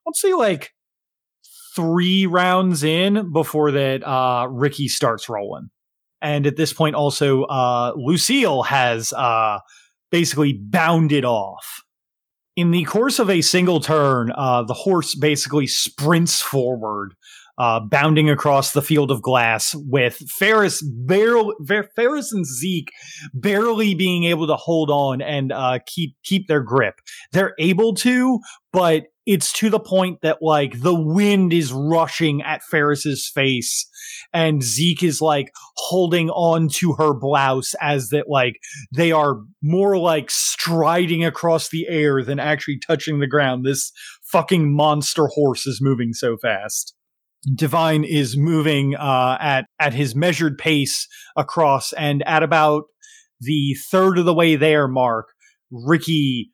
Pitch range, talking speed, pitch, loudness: 140-175 Hz, 140 wpm, 155 Hz, -18 LUFS